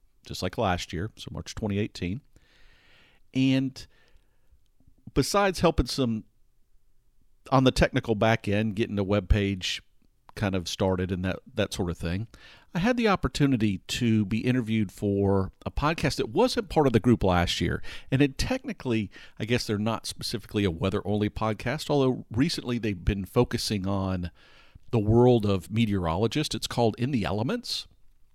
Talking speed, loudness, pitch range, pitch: 155 wpm, -27 LUFS, 100-125 Hz, 110 Hz